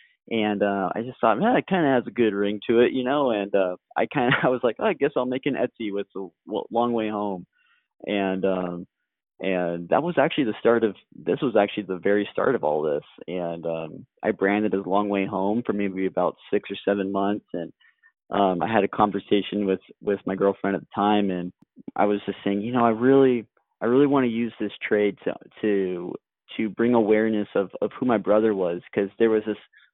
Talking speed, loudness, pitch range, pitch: 230 wpm, -24 LUFS, 95-115 Hz, 105 Hz